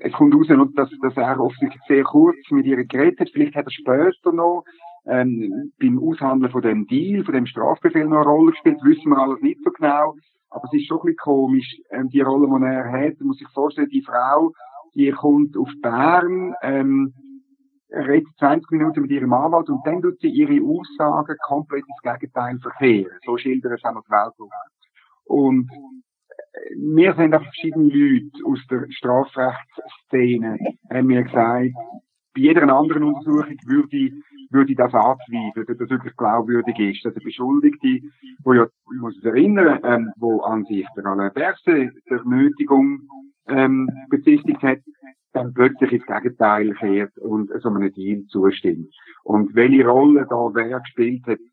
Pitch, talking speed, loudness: 145 Hz, 165 wpm, -19 LUFS